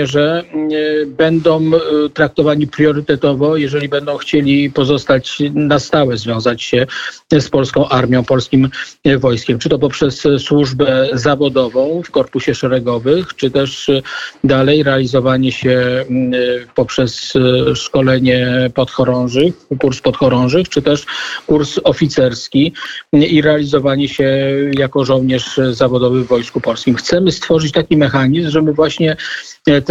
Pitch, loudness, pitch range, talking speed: 140 Hz, -13 LUFS, 130-150 Hz, 110 wpm